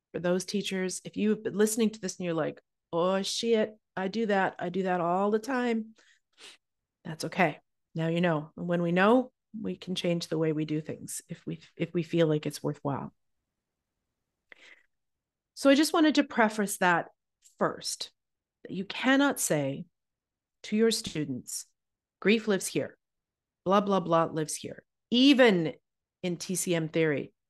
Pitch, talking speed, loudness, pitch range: 185 Hz, 160 wpm, -28 LUFS, 165-215 Hz